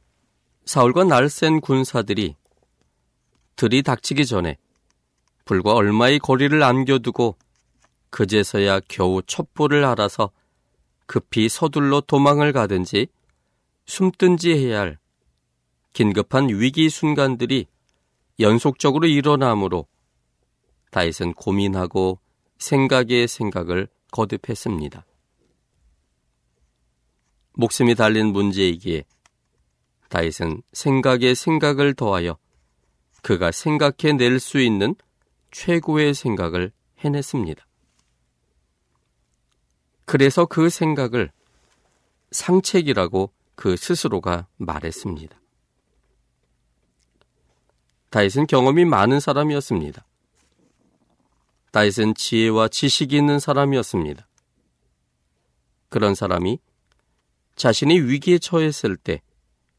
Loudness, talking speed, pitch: -20 LUFS, 210 characters per minute, 105 Hz